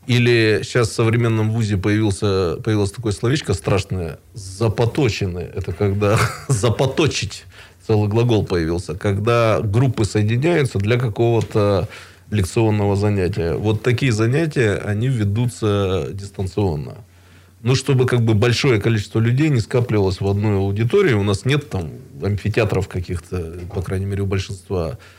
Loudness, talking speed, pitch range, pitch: -19 LUFS, 125 wpm, 100-120 Hz, 105 Hz